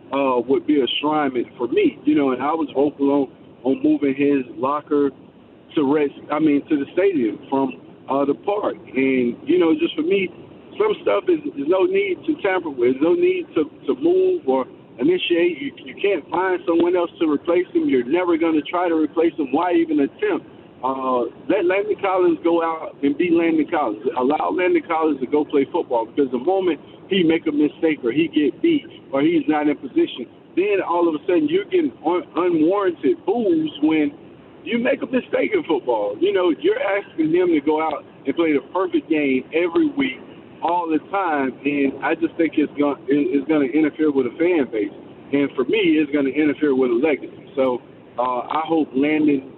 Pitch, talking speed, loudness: 170 Hz, 200 wpm, -20 LUFS